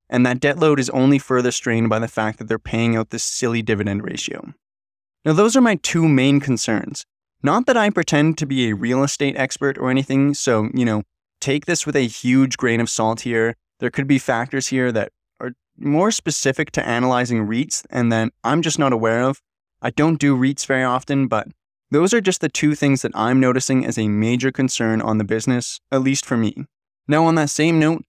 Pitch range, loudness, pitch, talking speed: 115-145 Hz, -19 LUFS, 130 Hz, 215 wpm